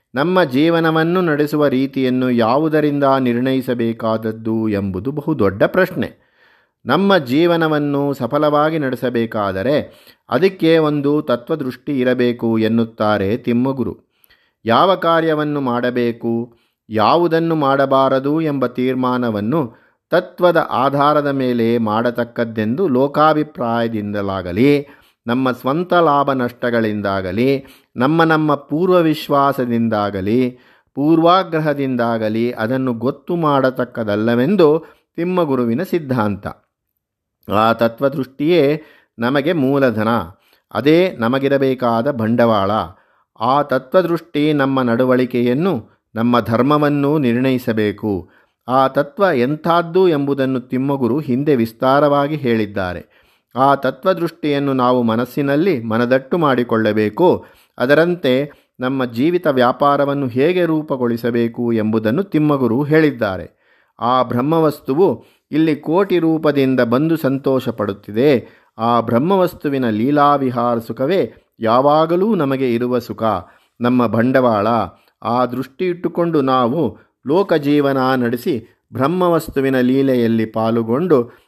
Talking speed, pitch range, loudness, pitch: 80 wpm, 115-150 Hz, -16 LUFS, 130 Hz